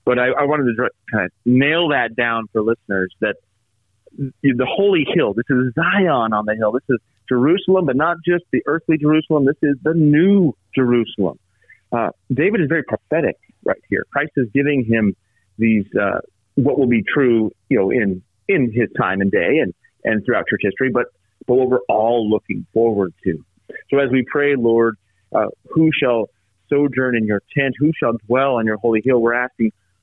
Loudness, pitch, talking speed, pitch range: -18 LUFS, 125 Hz, 190 wpm, 110-140 Hz